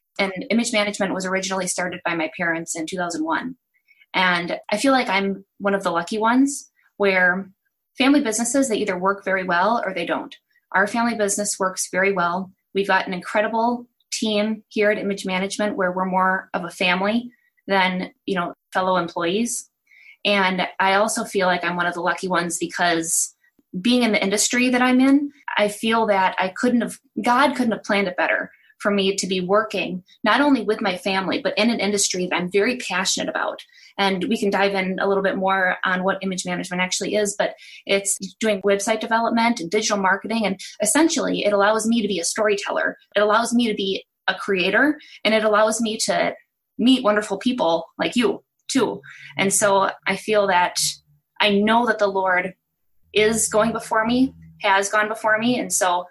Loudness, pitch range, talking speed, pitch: -21 LUFS, 185-225 Hz, 190 wpm, 200 Hz